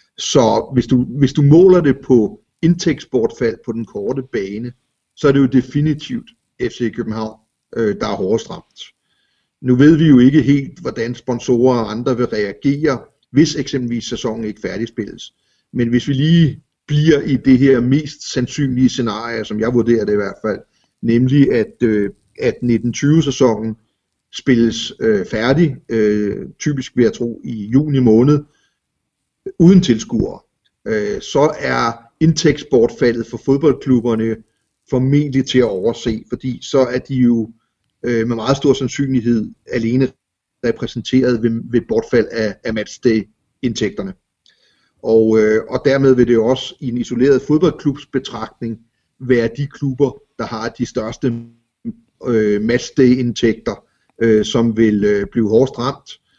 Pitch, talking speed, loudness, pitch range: 125 Hz, 130 wpm, -16 LUFS, 115-140 Hz